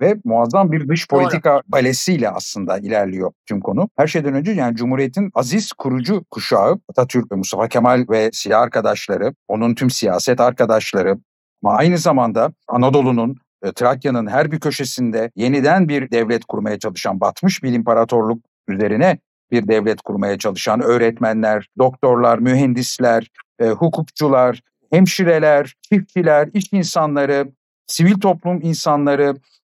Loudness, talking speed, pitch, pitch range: -17 LUFS, 125 wpm, 130 Hz, 115-155 Hz